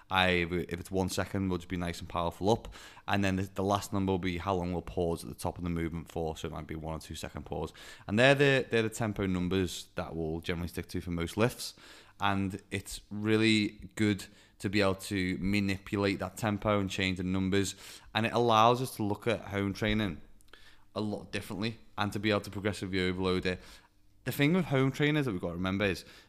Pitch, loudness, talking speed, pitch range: 100 Hz, -32 LUFS, 230 wpm, 90-105 Hz